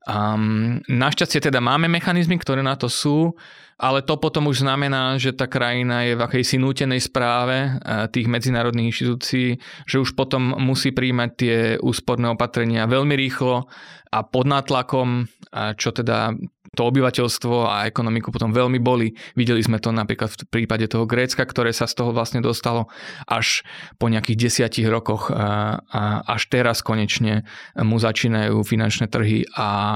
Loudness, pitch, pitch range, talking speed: -21 LUFS, 120 Hz, 115-130 Hz, 150 wpm